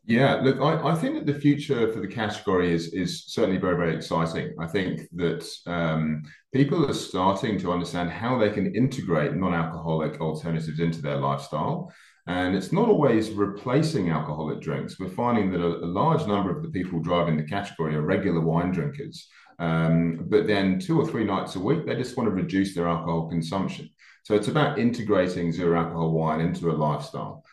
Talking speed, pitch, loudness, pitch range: 185 wpm, 85 Hz, -25 LUFS, 80-105 Hz